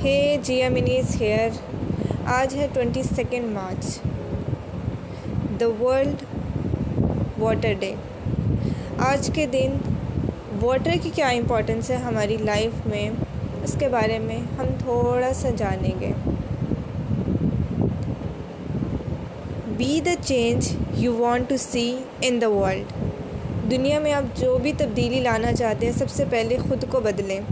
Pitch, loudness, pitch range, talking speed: 245 Hz, -24 LUFS, 205-270 Hz, 125 wpm